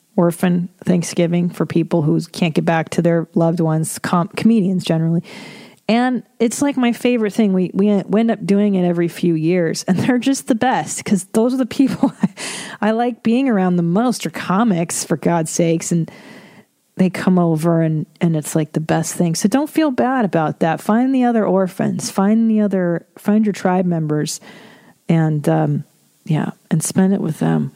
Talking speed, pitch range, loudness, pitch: 190 wpm, 170-220 Hz, -17 LUFS, 190 Hz